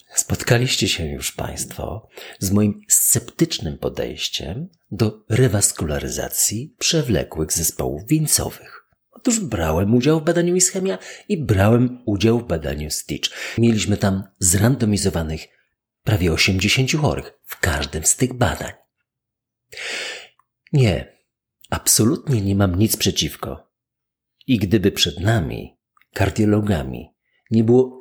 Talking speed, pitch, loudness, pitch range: 105 wpm, 105 Hz, -19 LUFS, 90-125 Hz